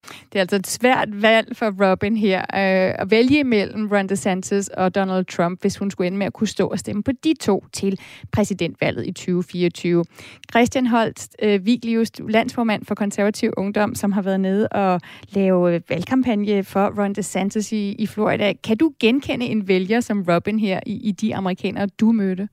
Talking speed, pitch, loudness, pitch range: 175 wpm, 200 Hz, -20 LUFS, 190-220 Hz